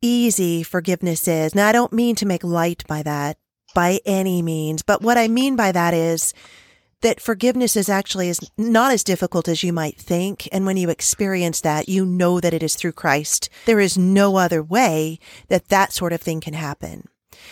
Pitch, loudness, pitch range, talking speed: 180 Hz, -19 LUFS, 165-200 Hz, 200 wpm